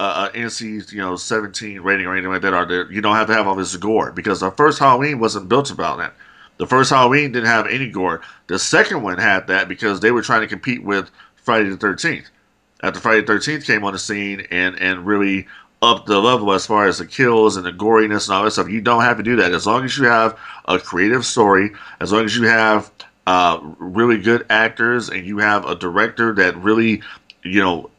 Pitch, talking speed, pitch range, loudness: 105 Hz, 230 wpm, 95-115 Hz, -17 LUFS